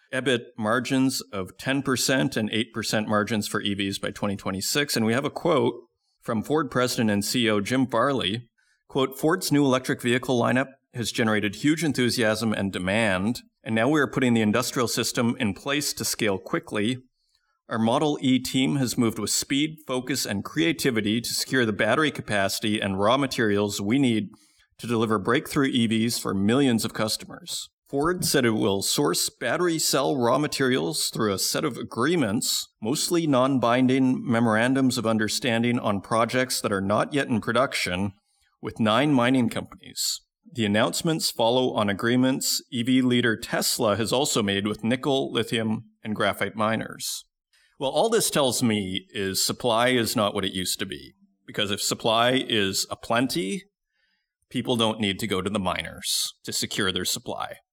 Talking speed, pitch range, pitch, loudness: 165 wpm, 105-130 Hz, 120 Hz, -24 LUFS